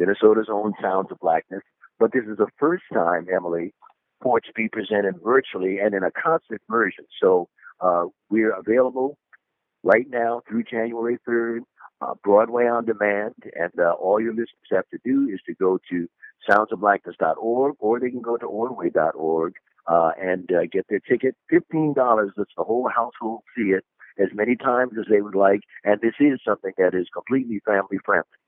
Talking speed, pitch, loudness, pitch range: 180 wpm, 110 Hz, -22 LUFS, 95-125 Hz